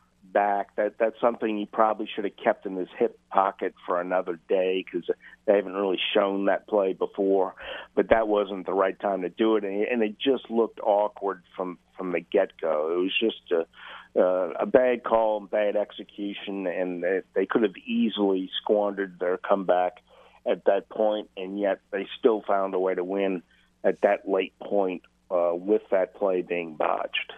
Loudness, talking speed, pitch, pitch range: -26 LUFS, 180 wpm, 100 Hz, 95-110 Hz